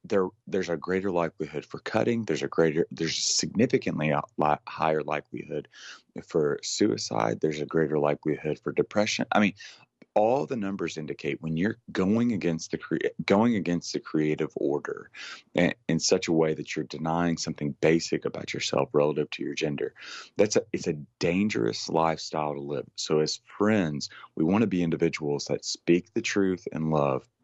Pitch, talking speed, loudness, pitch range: 80 Hz, 175 wpm, -27 LUFS, 75-85 Hz